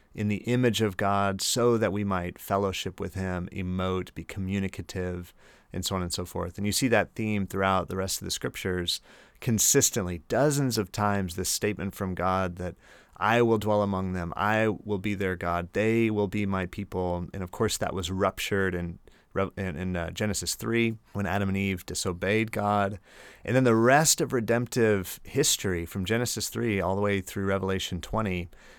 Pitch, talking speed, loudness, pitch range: 100 Hz, 185 wpm, -27 LUFS, 95-110 Hz